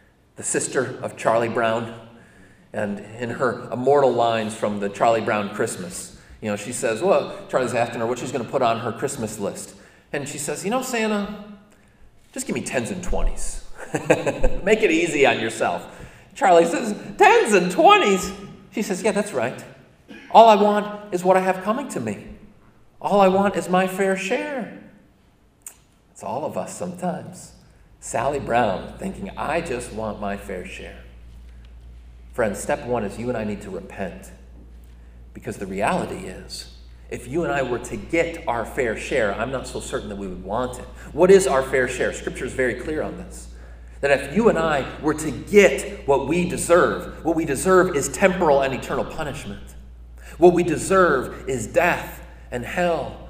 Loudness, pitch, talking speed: -21 LUFS, 135 Hz, 180 wpm